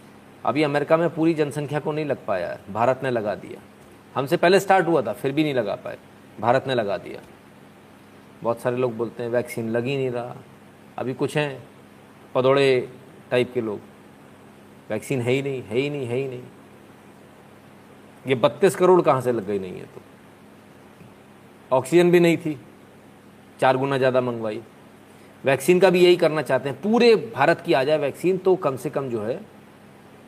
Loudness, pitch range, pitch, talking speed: -22 LUFS, 100-155 Hz, 130 Hz, 180 wpm